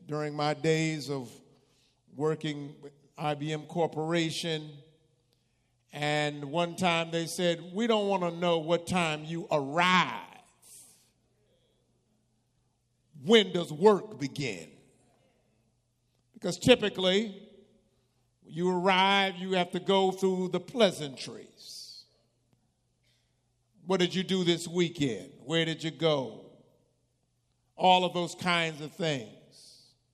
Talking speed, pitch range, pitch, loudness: 105 wpm, 130-180 Hz, 155 Hz, -29 LUFS